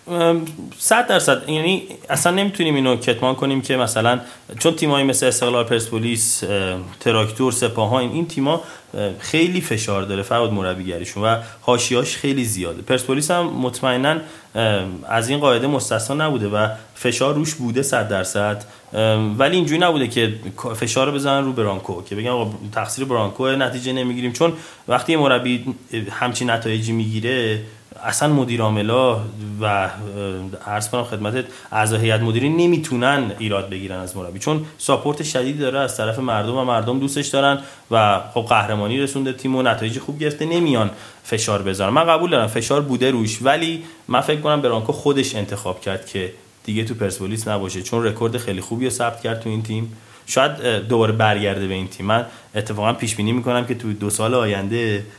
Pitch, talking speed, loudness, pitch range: 120 Hz, 160 wpm, -20 LUFS, 105-135 Hz